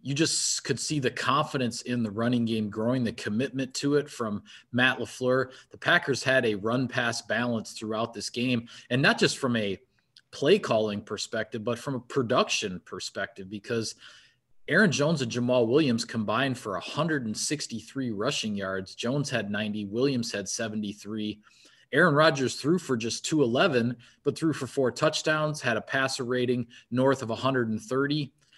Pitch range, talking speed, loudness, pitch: 110-135 Hz, 160 wpm, -27 LUFS, 125 Hz